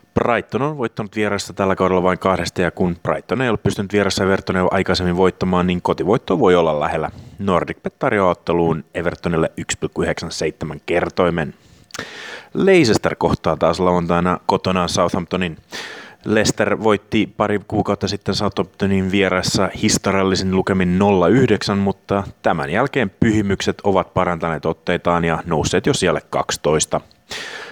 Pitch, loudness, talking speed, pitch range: 95 Hz, -18 LUFS, 120 wpm, 90-100 Hz